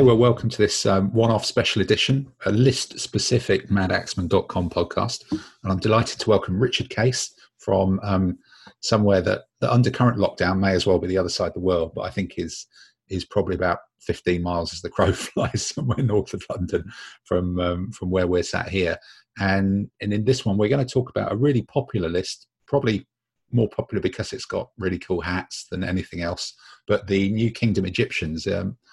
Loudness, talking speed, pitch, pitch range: -23 LUFS, 195 wpm, 100 Hz, 95-120 Hz